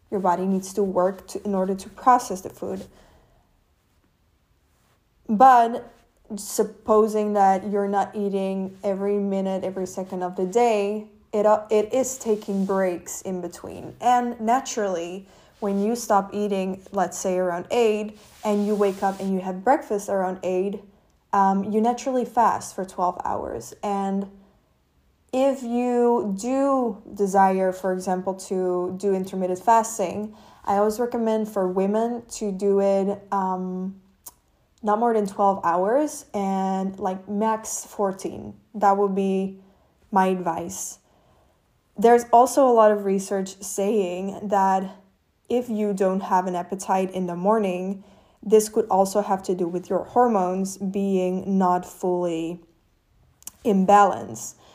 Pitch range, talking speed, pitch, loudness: 185-215 Hz, 135 wpm, 195 Hz, -23 LUFS